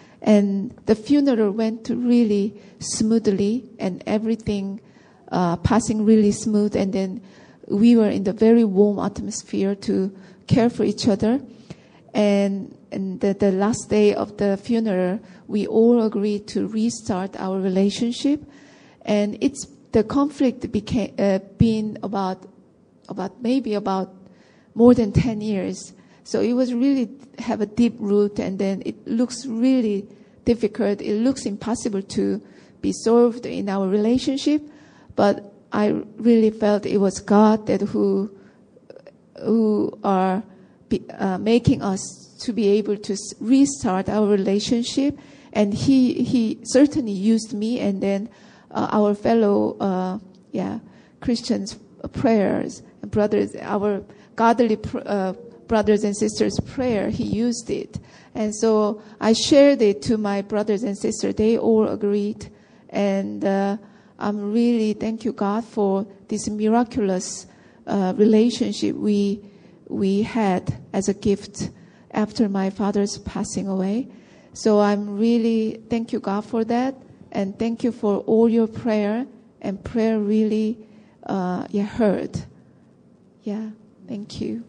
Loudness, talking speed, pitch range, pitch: -21 LUFS, 135 wpm, 200-230 Hz, 215 Hz